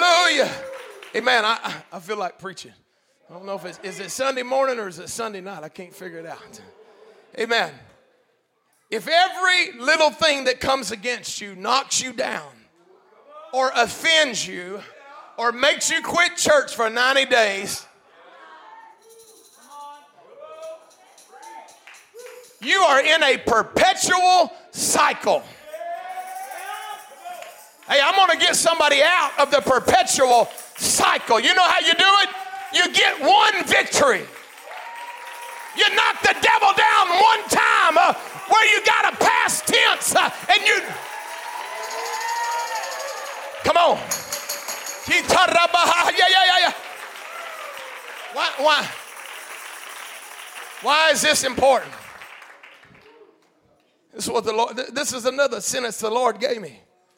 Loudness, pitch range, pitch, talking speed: -18 LUFS, 255-400 Hz, 325 Hz, 120 wpm